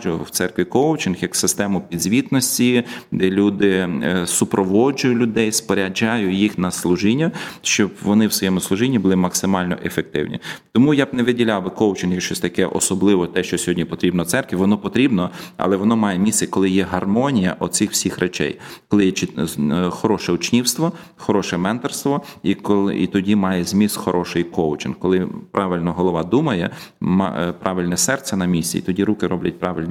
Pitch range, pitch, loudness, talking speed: 90-105 Hz, 95 Hz, -19 LUFS, 155 wpm